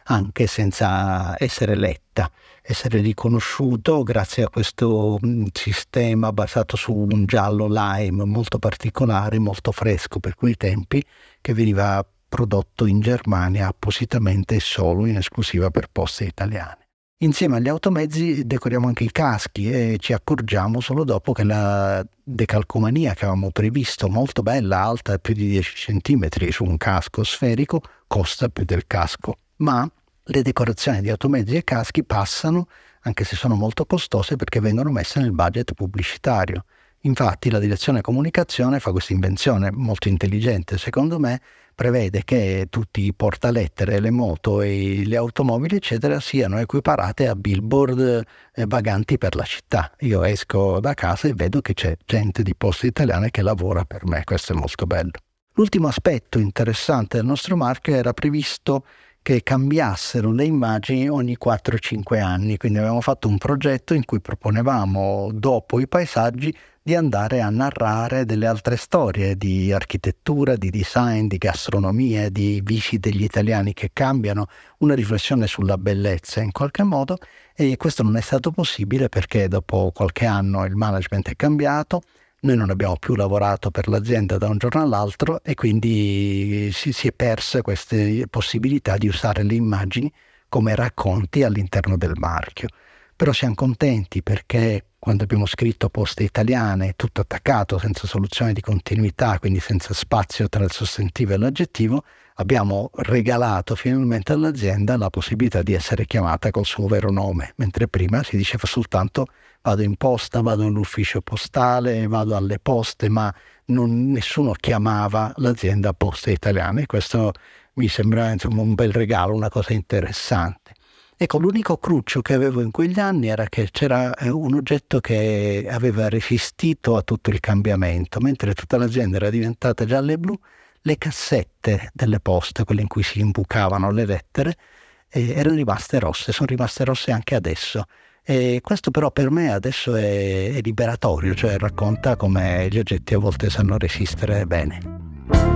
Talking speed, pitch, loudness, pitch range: 150 wpm, 110 Hz, -21 LUFS, 100-125 Hz